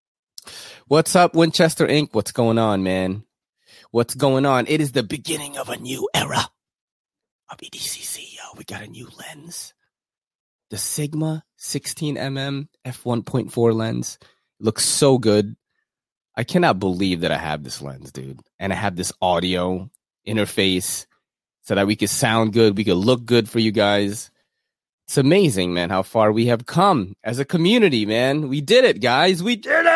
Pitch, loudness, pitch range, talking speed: 115 Hz, -20 LUFS, 100-150 Hz, 170 wpm